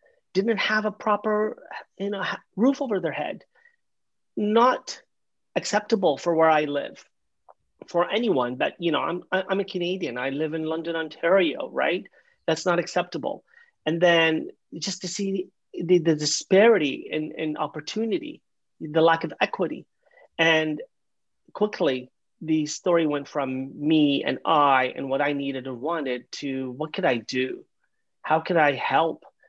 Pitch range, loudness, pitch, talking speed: 150-195 Hz, -24 LUFS, 165 Hz, 150 wpm